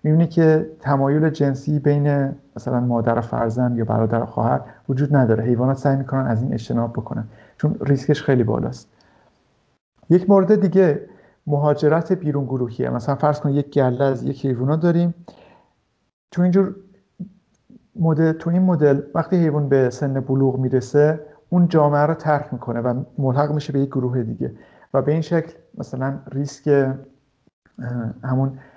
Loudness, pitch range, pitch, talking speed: -20 LUFS, 130-155 Hz, 140 Hz, 150 wpm